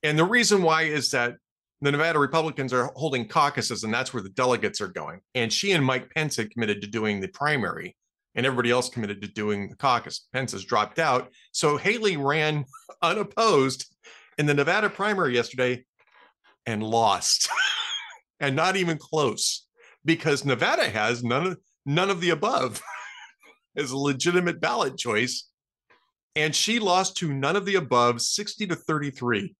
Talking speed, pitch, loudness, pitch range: 165 wpm, 140 Hz, -25 LUFS, 120-170 Hz